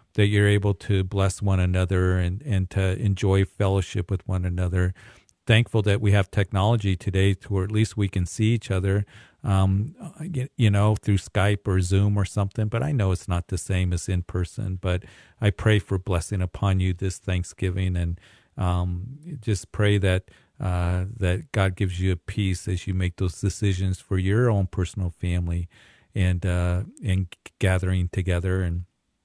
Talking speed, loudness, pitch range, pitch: 175 wpm, -25 LUFS, 90-105 Hz, 95 Hz